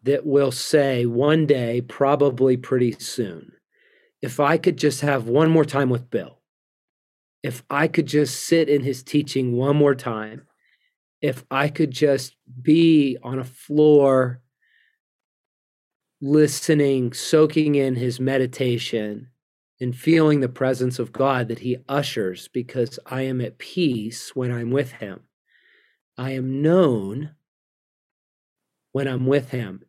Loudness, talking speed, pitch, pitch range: -21 LUFS, 135 wpm, 135 Hz, 125-150 Hz